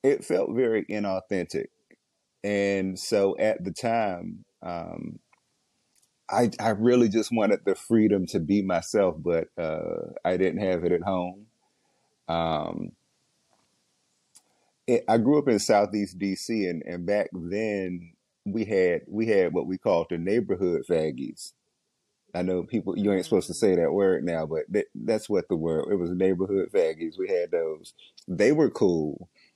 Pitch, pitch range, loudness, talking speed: 100 Hz, 95-115 Hz, -26 LUFS, 155 wpm